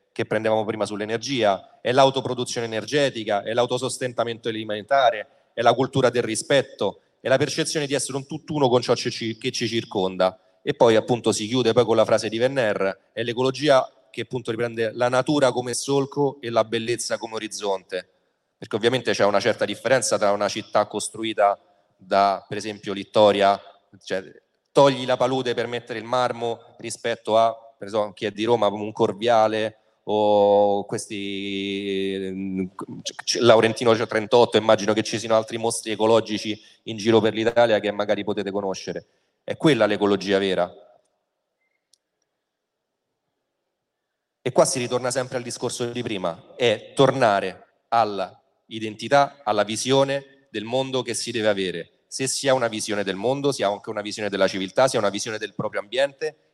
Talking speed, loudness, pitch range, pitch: 160 wpm, -22 LUFS, 105-125 Hz, 115 Hz